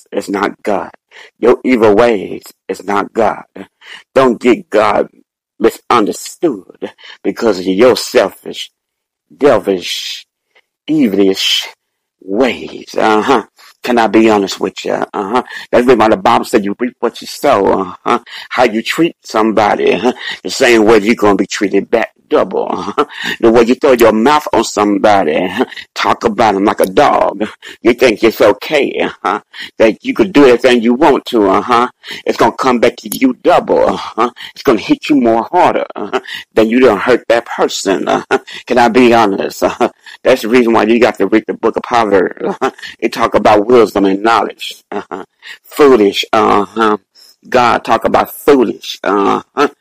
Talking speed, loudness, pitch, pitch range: 170 wpm, -12 LUFS, 115 Hz, 110-150 Hz